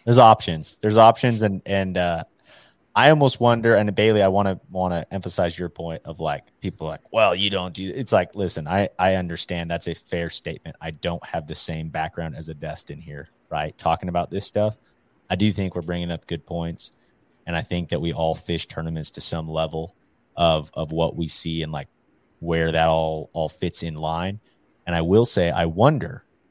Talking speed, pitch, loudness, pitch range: 215 wpm, 85 Hz, -22 LUFS, 80-100 Hz